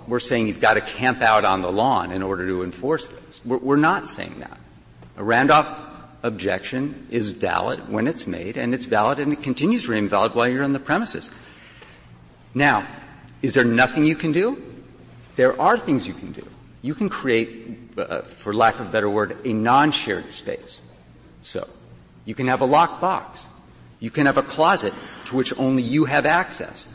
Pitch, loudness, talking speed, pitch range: 115 Hz, -21 LUFS, 190 wpm, 95-135 Hz